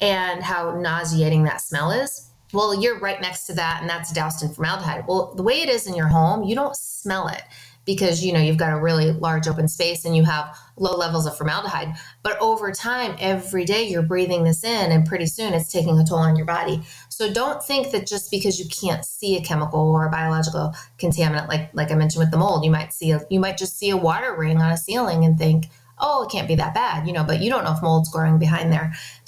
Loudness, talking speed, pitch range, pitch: -21 LUFS, 245 wpm, 160-190 Hz, 165 Hz